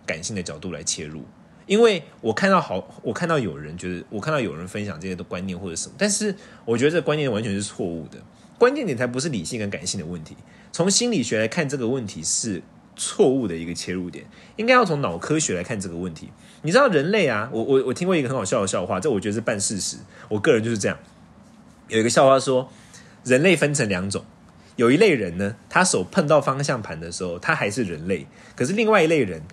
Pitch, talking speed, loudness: 115 Hz, 345 characters per minute, -22 LUFS